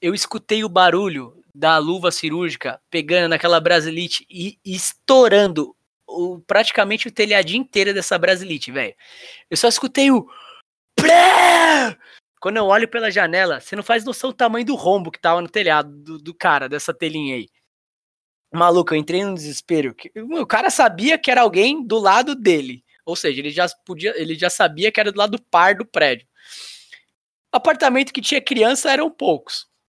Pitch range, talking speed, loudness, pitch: 170-245 Hz, 165 wpm, -17 LUFS, 195 Hz